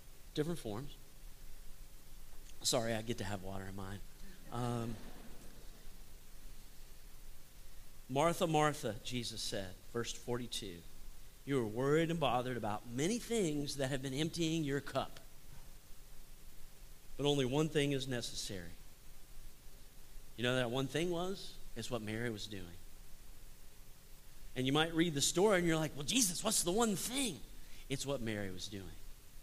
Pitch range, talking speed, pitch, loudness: 100-150 Hz, 140 wpm, 125 Hz, -37 LUFS